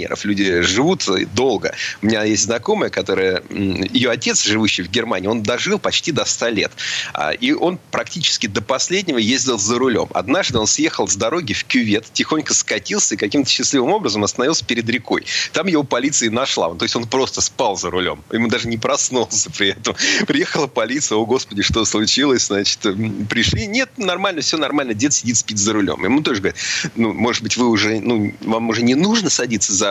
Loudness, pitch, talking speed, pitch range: -17 LUFS, 115 Hz, 185 wpm, 105-125 Hz